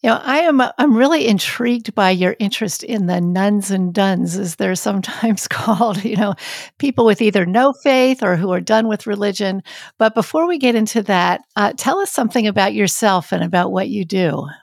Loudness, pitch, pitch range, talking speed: -16 LUFS, 210 Hz, 190-240 Hz, 200 wpm